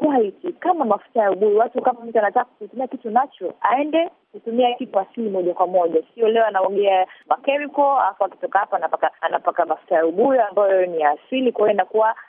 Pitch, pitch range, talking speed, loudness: 215 Hz, 185-255 Hz, 180 wpm, -20 LUFS